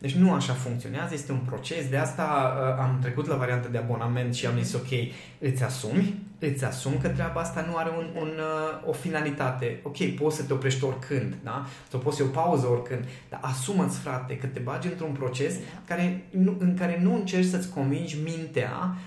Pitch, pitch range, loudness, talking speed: 145 Hz, 130-165 Hz, -28 LUFS, 200 wpm